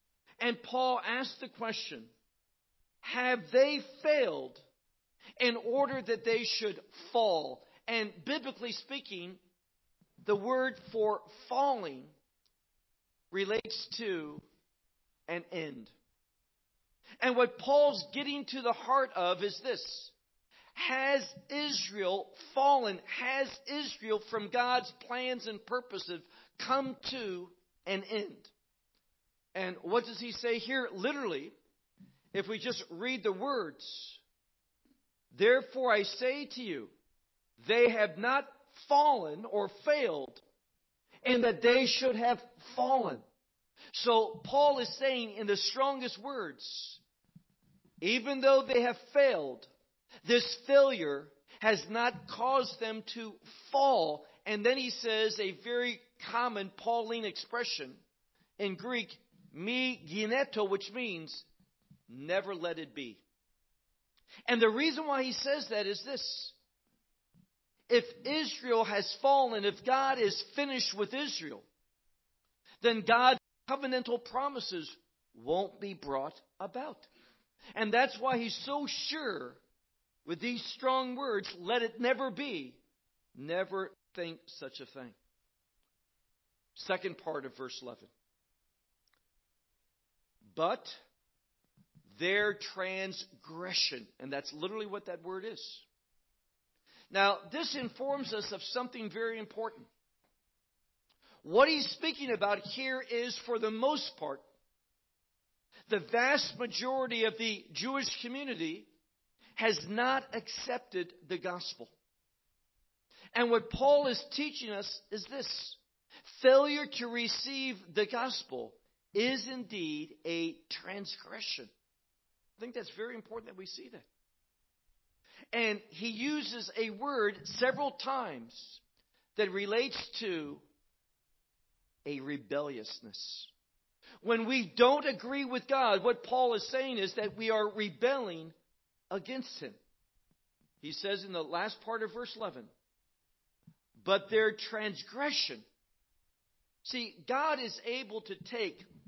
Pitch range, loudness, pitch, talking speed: 200-260 Hz, -33 LUFS, 235 Hz, 115 wpm